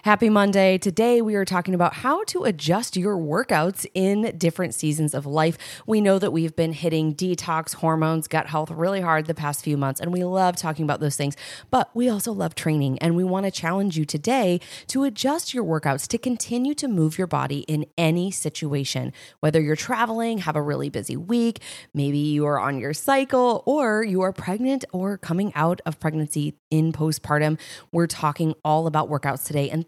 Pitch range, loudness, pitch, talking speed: 155-205 Hz, -23 LUFS, 170 Hz, 195 wpm